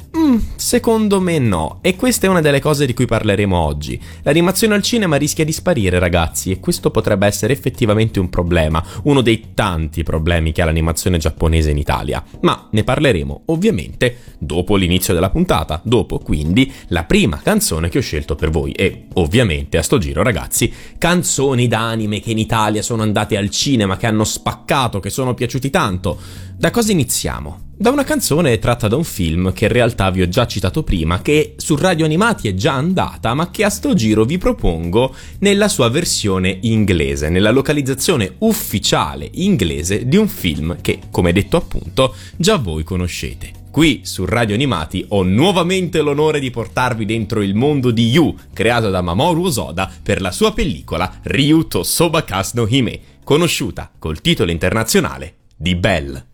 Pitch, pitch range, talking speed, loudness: 110 Hz, 90-145 Hz, 170 wpm, -16 LUFS